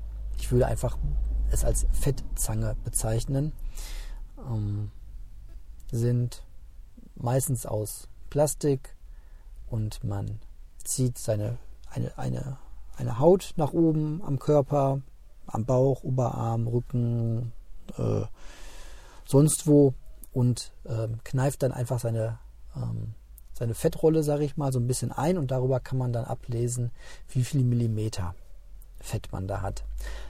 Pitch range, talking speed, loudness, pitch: 110-135 Hz, 120 wpm, -28 LUFS, 120 Hz